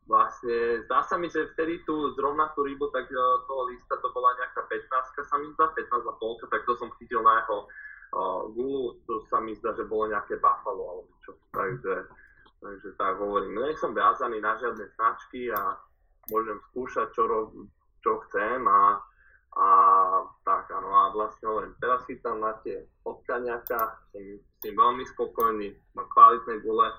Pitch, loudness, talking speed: 370 Hz, -26 LUFS, 175 wpm